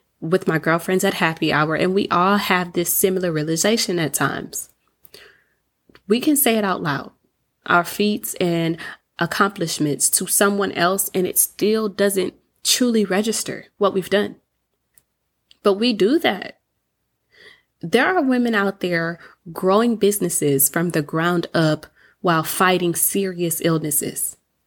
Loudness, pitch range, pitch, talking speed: -19 LUFS, 165-205 Hz, 185 Hz, 135 wpm